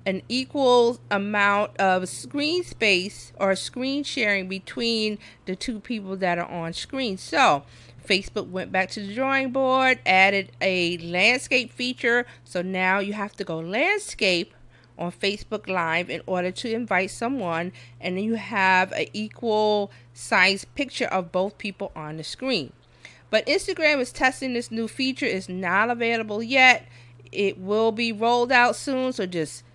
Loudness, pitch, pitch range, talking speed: -23 LUFS, 205 Hz, 185-245 Hz, 155 wpm